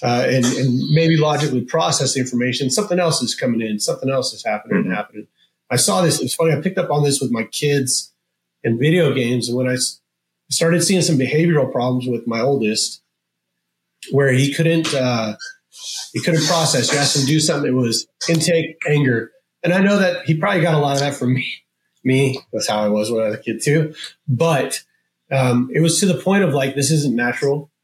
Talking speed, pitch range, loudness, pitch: 215 wpm, 125-160 Hz, -18 LUFS, 140 Hz